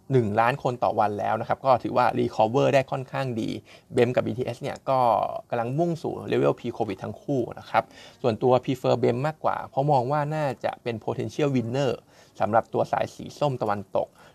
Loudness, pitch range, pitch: -25 LUFS, 115-140 Hz, 130 Hz